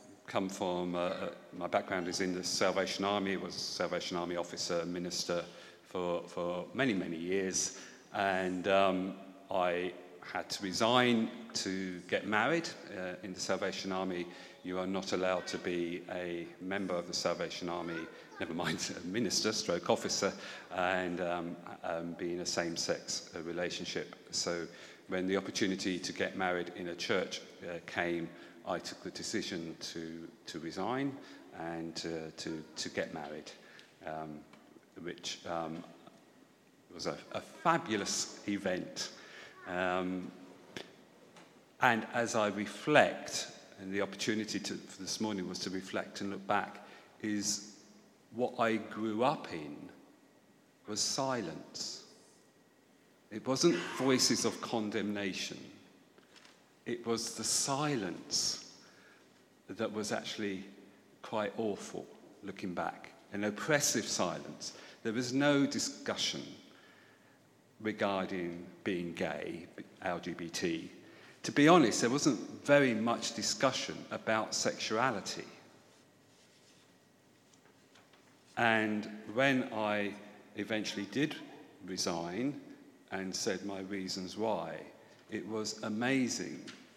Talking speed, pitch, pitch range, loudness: 120 wpm, 95 Hz, 90-110 Hz, -35 LUFS